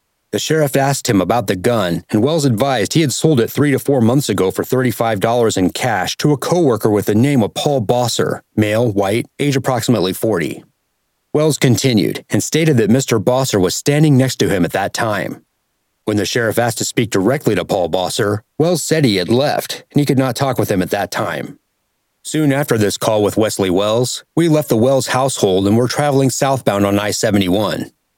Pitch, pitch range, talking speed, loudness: 125 Hz, 105-140 Hz, 205 wpm, -15 LUFS